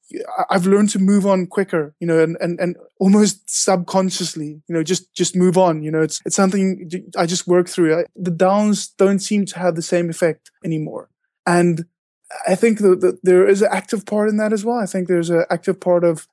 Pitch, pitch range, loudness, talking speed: 185 Hz, 170-195 Hz, -18 LUFS, 220 wpm